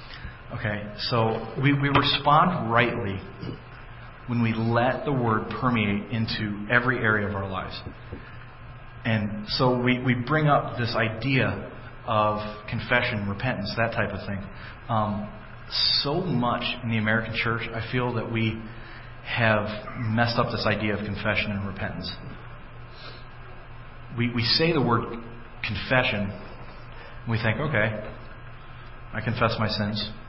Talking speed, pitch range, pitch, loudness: 135 wpm, 105-120 Hz, 115 Hz, -25 LUFS